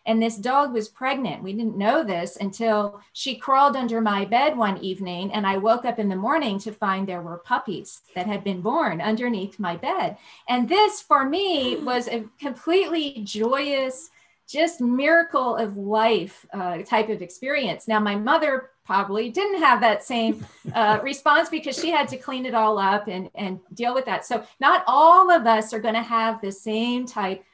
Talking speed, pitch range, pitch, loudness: 190 wpm, 205-275 Hz, 225 Hz, -22 LUFS